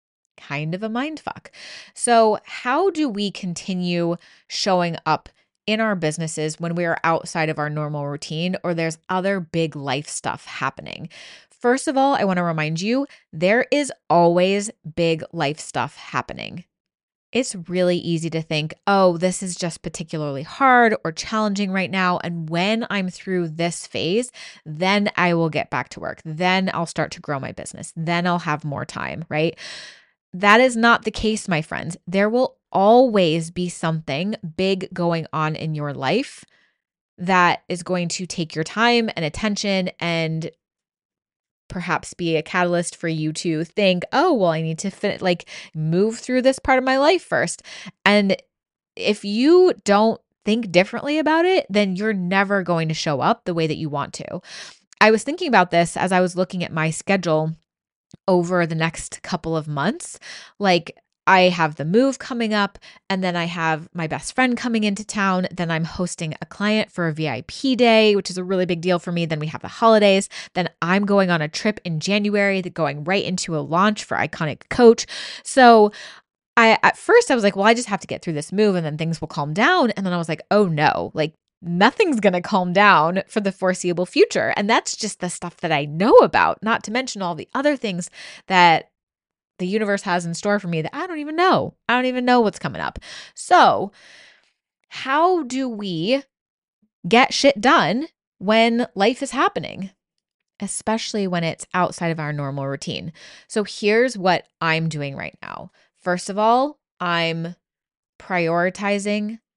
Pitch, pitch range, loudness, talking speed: 185 Hz, 165-215 Hz, -20 LUFS, 185 wpm